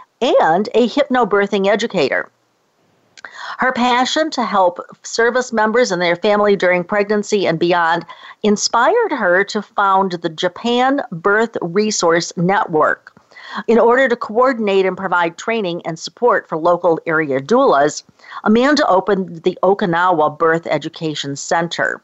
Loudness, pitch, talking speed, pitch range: -16 LUFS, 200 Hz, 125 wpm, 175-230 Hz